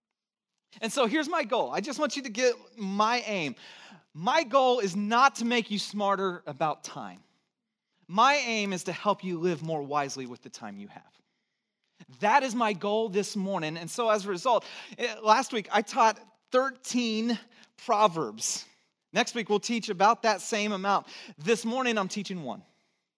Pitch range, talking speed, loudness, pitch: 195-240 Hz, 175 wpm, -28 LUFS, 215 Hz